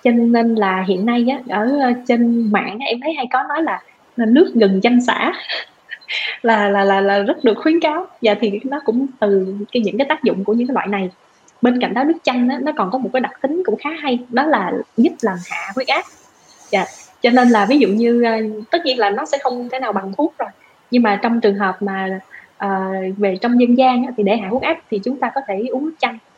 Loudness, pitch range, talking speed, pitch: -17 LUFS, 210-260 Hz, 245 wpm, 240 Hz